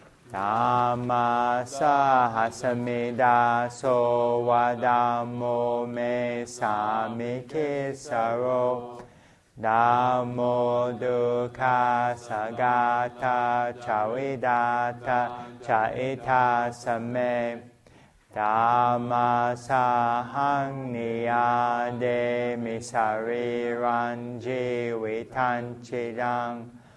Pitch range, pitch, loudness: 120-125 Hz, 120 Hz, -26 LUFS